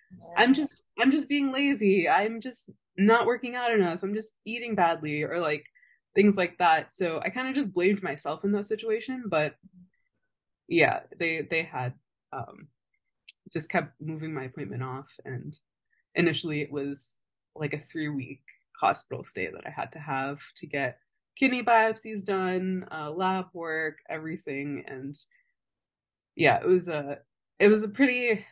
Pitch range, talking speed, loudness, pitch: 150-220 Hz, 160 wpm, -27 LUFS, 180 Hz